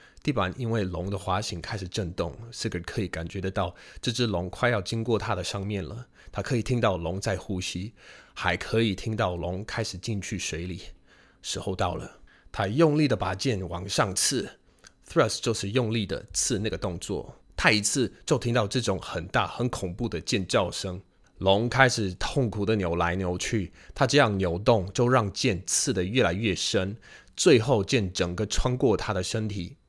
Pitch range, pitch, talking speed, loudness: 90-115 Hz, 100 Hz, 270 characters per minute, -27 LUFS